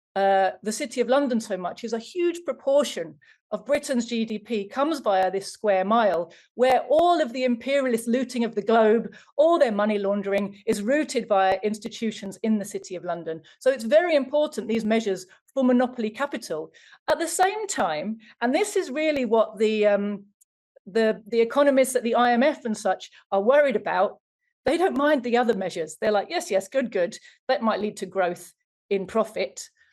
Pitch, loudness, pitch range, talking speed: 225 Hz, -24 LUFS, 200-275 Hz, 180 wpm